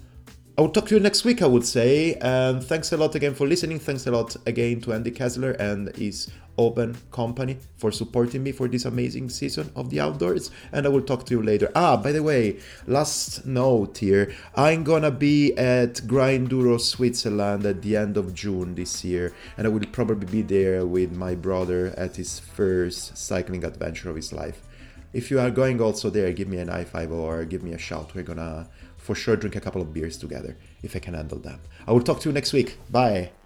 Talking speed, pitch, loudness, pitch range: 215 wpm, 110 Hz, -24 LUFS, 90-125 Hz